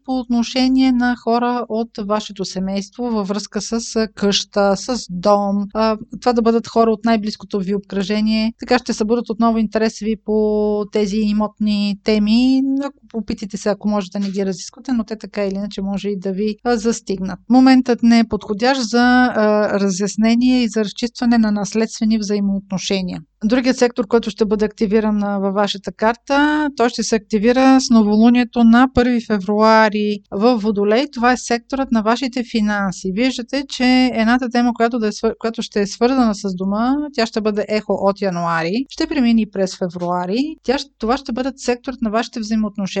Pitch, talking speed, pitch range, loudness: 225 Hz, 165 wpm, 205-245 Hz, -17 LUFS